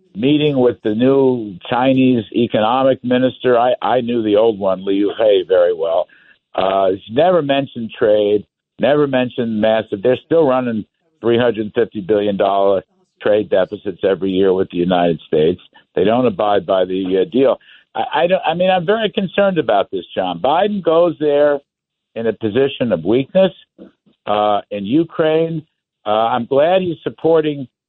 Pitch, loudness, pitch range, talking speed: 125 Hz, -16 LUFS, 105-160 Hz, 165 wpm